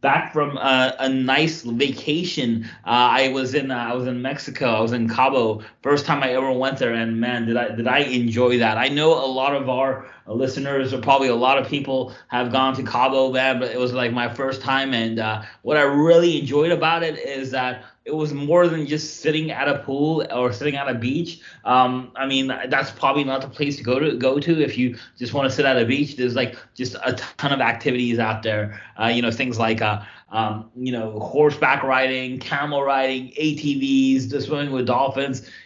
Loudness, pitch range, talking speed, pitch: -21 LUFS, 125-140 Hz, 220 wpm, 130 Hz